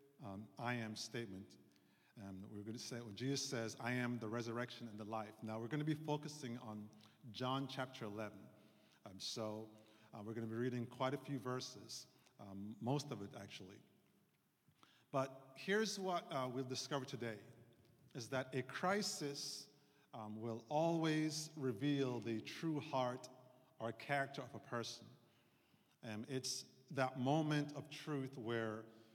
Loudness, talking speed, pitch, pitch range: -44 LUFS, 160 wpm, 125 Hz, 110-140 Hz